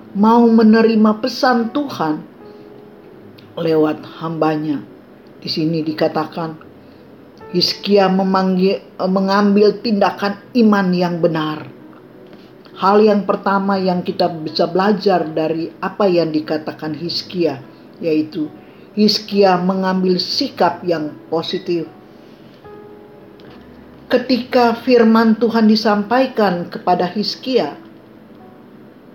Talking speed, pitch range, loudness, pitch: 80 wpm, 165-215 Hz, -16 LUFS, 190 Hz